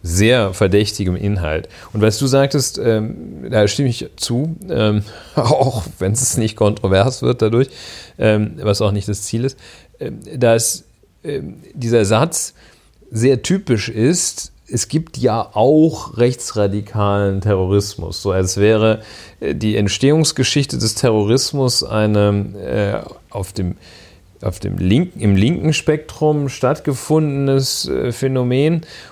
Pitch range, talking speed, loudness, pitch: 100-135 Hz, 130 wpm, -17 LUFS, 110 Hz